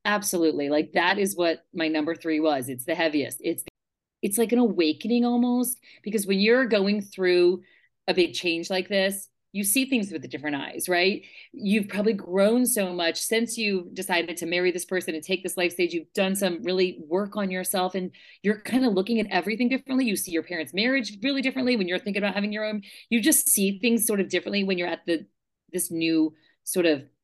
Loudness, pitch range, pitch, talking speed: -25 LUFS, 170-215 Hz, 190 Hz, 215 wpm